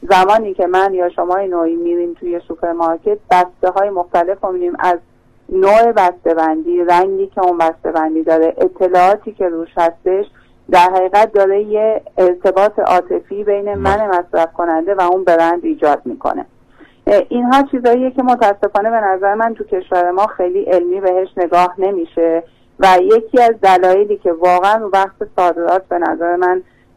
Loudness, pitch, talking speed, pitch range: -14 LUFS, 185 Hz, 155 wpm, 175-205 Hz